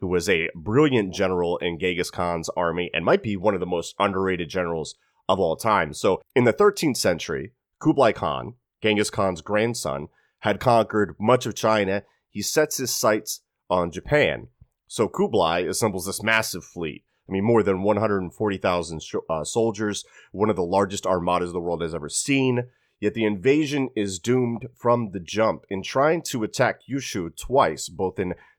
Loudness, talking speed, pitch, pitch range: -23 LUFS, 170 wpm, 105 Hz, 90-115 Hz